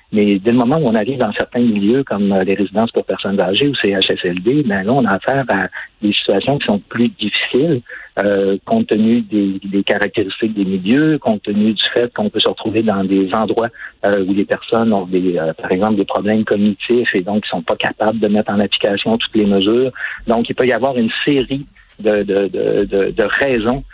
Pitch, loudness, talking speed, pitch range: 105 Hz, -16 LUFS, 225 wpm, 100-120 Hz